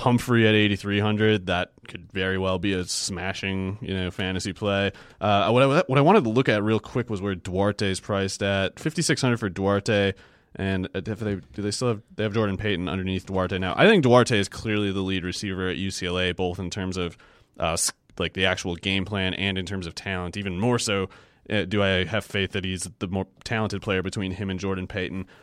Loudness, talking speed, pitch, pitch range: -25 LUFS, 225 wpm, 95 Hz, 95-105 Hz